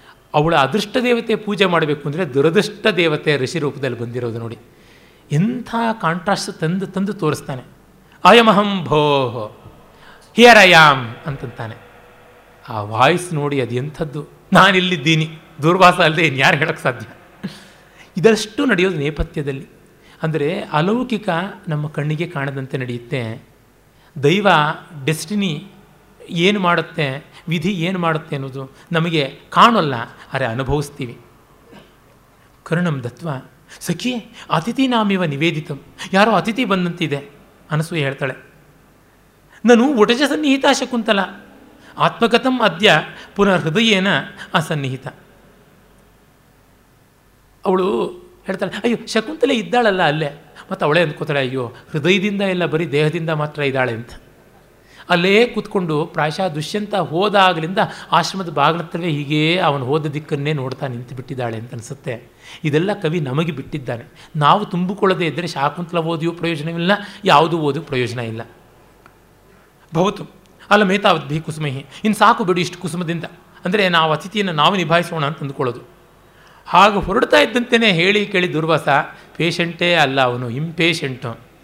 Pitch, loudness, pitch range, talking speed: 165 Hz, -17 LUFS, 145-195 Hz, 110 wpm